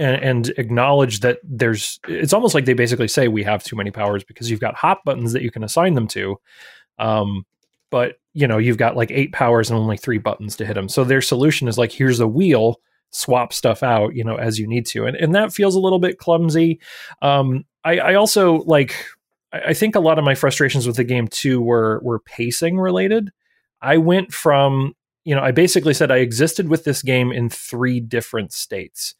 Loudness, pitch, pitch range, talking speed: -18 LUFS, 130 Hz, 115-155 Hz, 215 wpm